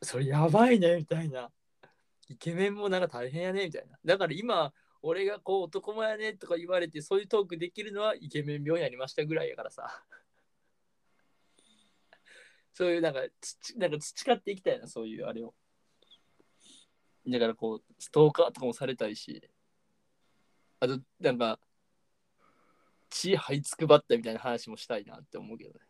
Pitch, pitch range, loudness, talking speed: 170 Hz, 140-205 Hz, -30 LUFS, 345 characters per minute